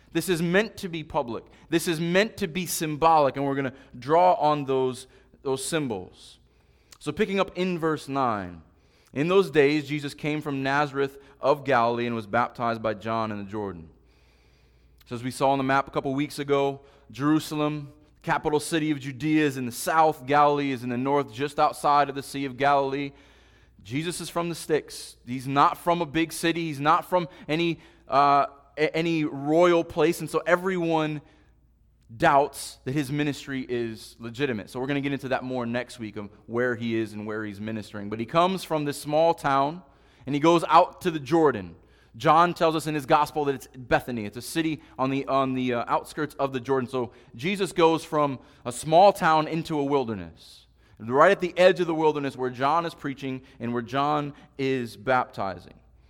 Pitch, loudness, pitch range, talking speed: 140 Hz, -25 LUFS, 125-160 Hz, 195 wpm